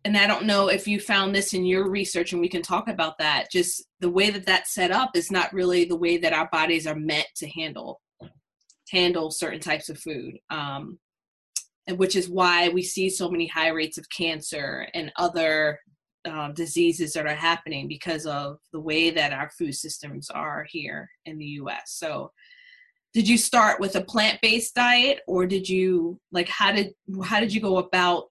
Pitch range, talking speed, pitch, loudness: 160-195 Hz, 200 wpm, 175 Hz, -24 LUFS